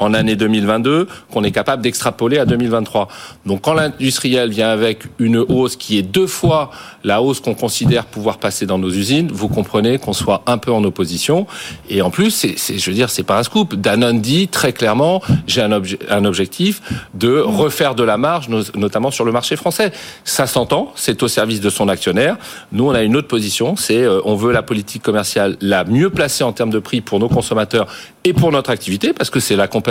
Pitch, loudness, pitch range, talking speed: 115 Hz, -16 LUFS, 105-130 Hz, 215 wpm